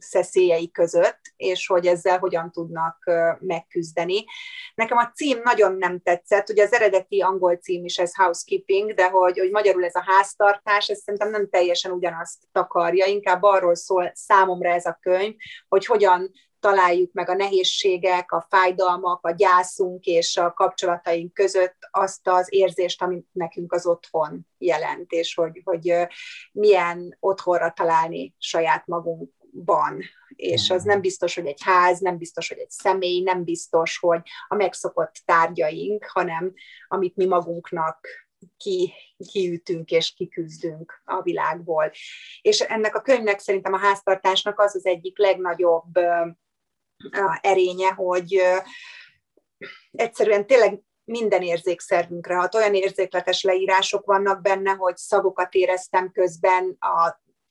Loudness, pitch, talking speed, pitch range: -21 LUFS, 185 Hz, 135 wpm, 175-195 Hz